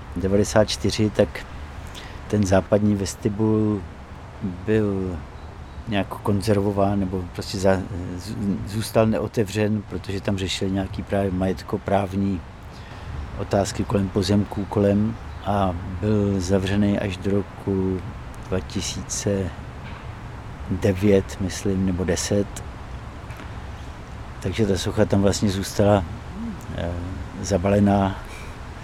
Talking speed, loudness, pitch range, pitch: 85 wpm, -23 LUFS, 95-105 Hz, 100 Hz